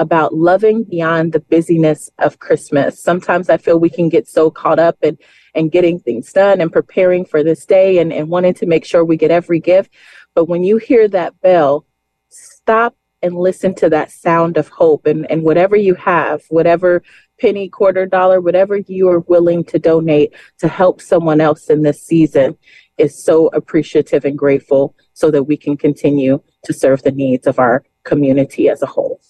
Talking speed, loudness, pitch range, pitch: 190 wpm, -13 LUFS, 155-185 Hz, 170 Hz